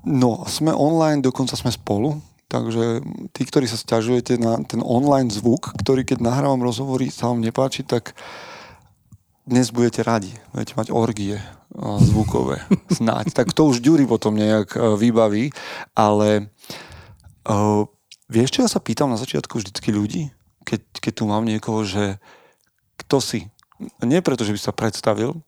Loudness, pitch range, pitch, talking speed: -20 LUFS, 105-130 Hz, 115 Hz, 150 wpm